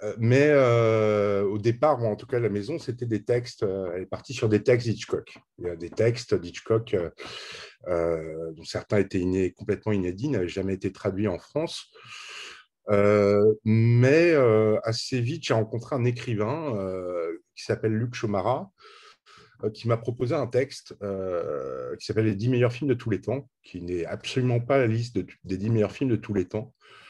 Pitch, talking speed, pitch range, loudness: 110 Hz, 195 wpm, 100-125 Hz, -26 LUFS